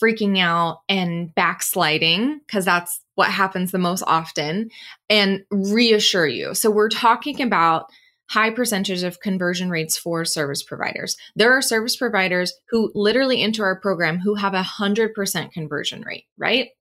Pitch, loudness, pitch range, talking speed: 195 Hz, -20 LUFS, 175-220 Hz, 150 wpm